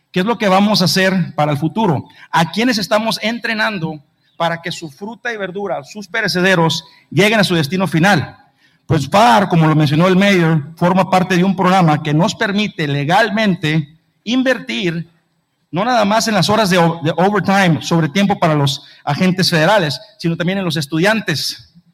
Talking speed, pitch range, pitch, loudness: 170 wpm, 160-205 Hz, 180 Hz, -15 LUFS